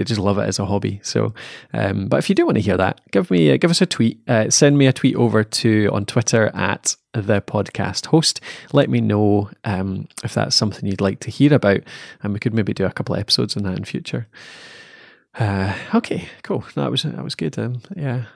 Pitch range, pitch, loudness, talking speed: 100-140 Hz, 115 Hz, -19 LUFS, 240 wpm